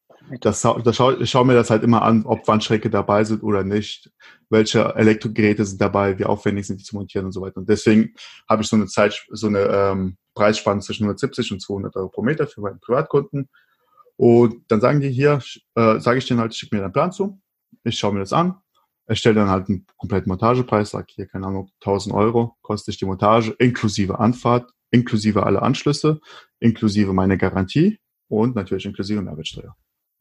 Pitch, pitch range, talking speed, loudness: 110 Hz, 100-120 Hz, 195 wpm, -19 LUFS